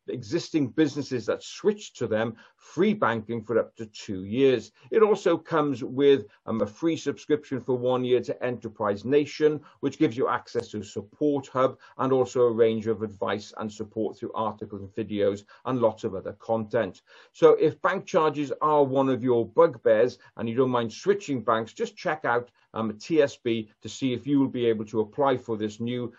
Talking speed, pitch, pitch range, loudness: 195 wpm, 125 Hz, 110-145 Hz, -26 LUFS